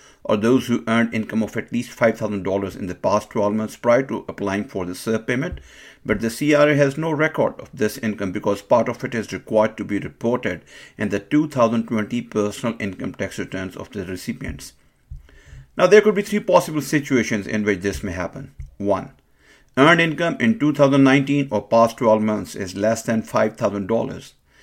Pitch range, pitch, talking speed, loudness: 100-130 Hz, 110 Hz, 180 wpm, -20 LUFS